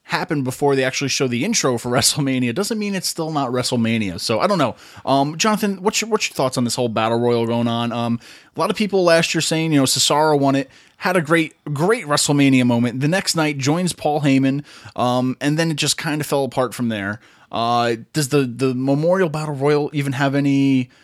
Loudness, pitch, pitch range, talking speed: -19 LUFS, 140 Hz, 125-160 Hz, 225 wpm